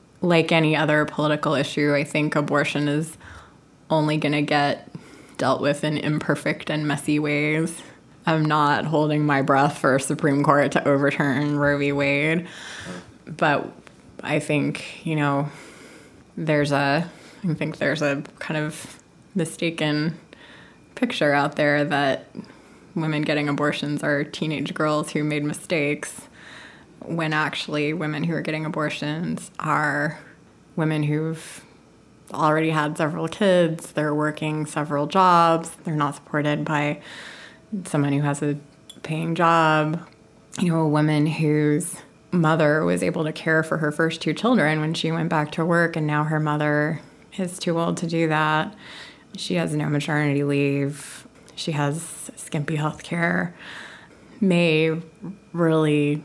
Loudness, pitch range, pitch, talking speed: -22 LUFS, 145-160 Hz, 150 Hz, 140 wpm